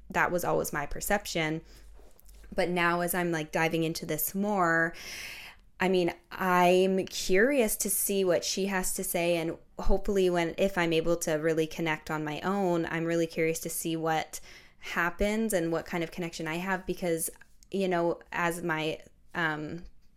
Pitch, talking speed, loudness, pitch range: 175 Hz, 170 wpm, -29 LUFS, 165-185 Hz